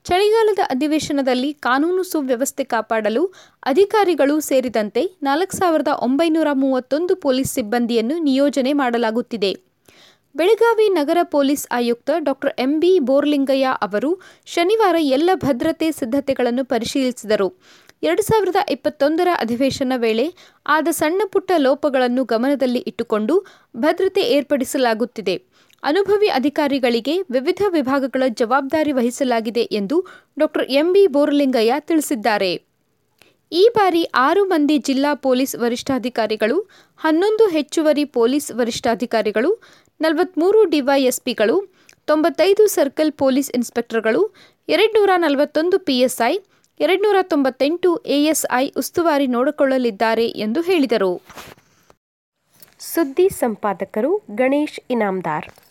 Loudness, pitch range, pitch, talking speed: -18 LUFS, 250-335 Hz, 280 Hz, 90 wpm